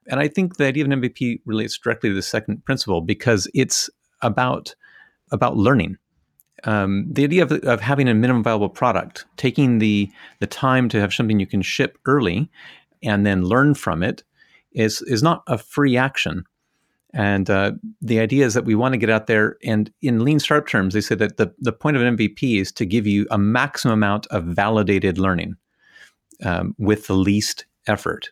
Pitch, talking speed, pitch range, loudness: 110 Hz, 195 wpm, 100-130 Hz, -20 LUFS